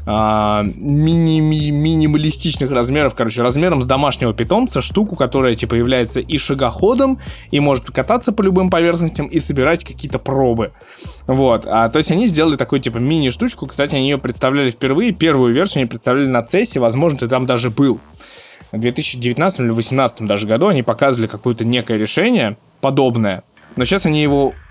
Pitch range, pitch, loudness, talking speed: 120-155 Hz, 135 Hz, -16 LUFS, 155 wpm